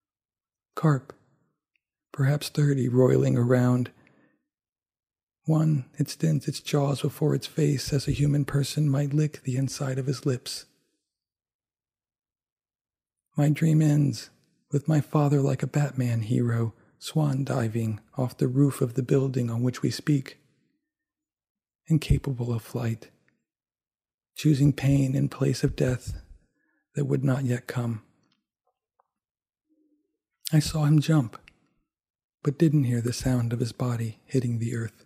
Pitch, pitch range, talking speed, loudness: 140 Hz, 125-150 Hz, 130 wpm, -26 LUFS